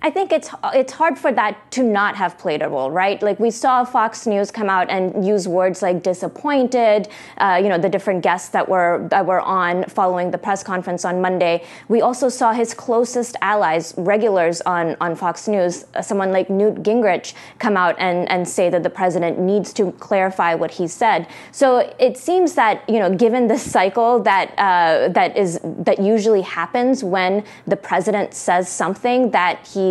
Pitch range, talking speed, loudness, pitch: 180-230 Hz, 190 wpm, -18 LUFS, 195 Hz